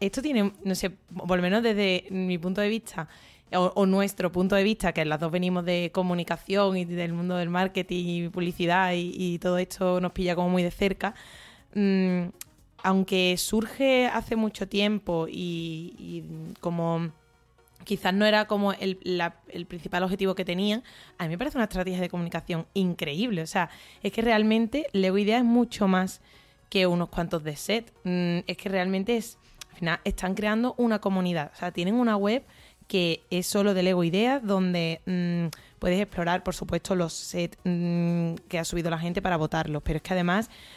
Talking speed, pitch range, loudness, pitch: 185 wpm, 175-200 Hz, -27 LUFS, 185 Hz